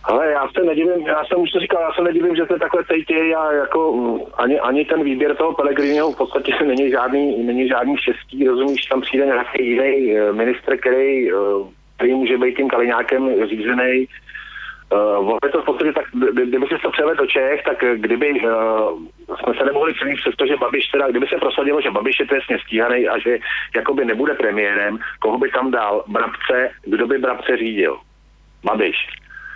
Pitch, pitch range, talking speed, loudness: 140 Hz, 125-175 Hz, 180 wpm, -18 LUFS